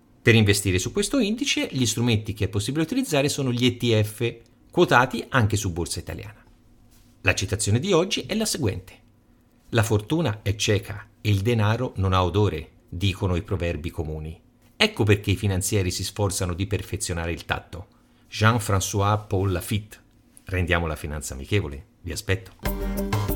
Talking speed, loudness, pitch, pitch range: 150 wpm, -24 LUFS, 105 Hz, 95-120 Hz